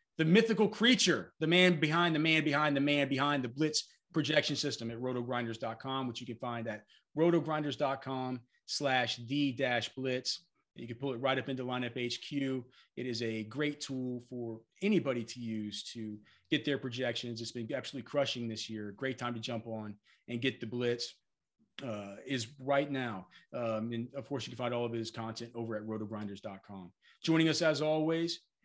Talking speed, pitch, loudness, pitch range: 175 wpm, 125 Hz, -34 LUFS, 115-145 Hz